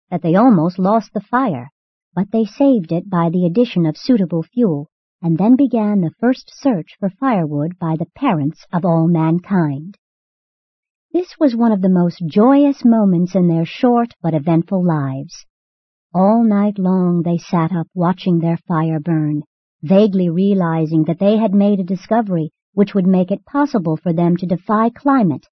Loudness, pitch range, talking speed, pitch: -16 LUFS, 165-220 Hz, 170 wpm, 185 Hz